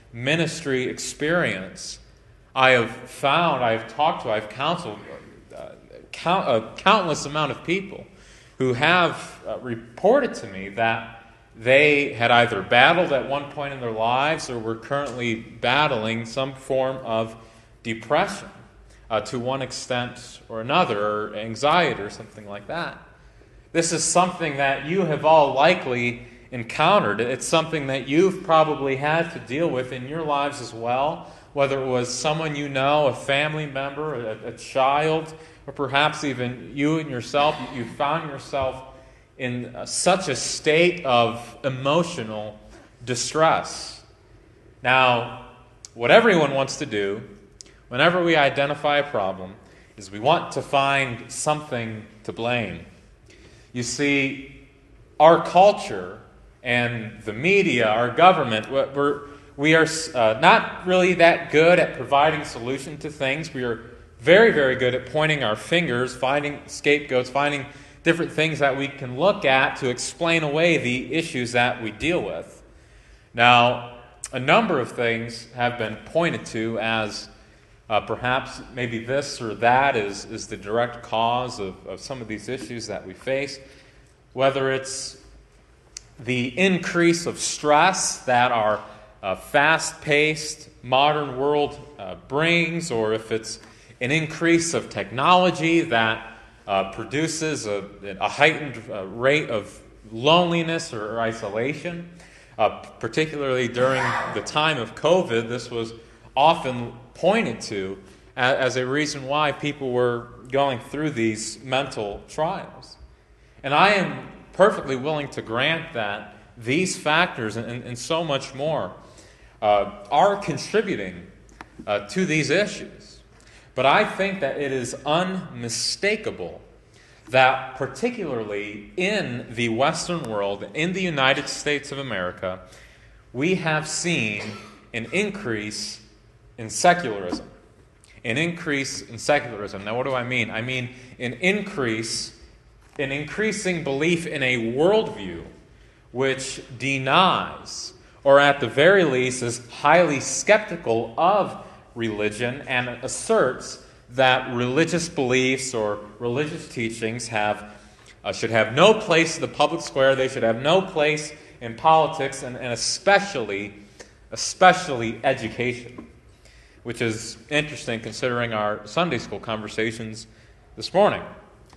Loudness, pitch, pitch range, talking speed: -22 LUFS, 130 Hz, 115-150 Hz, 135 wpm